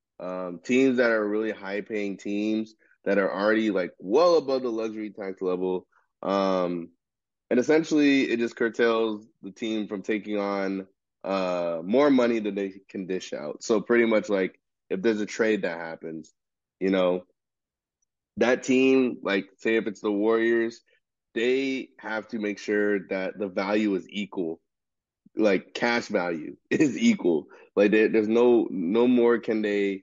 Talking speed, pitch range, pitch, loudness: 160 wpm, 95-115 Hz, 105 Hz, -25 LUFS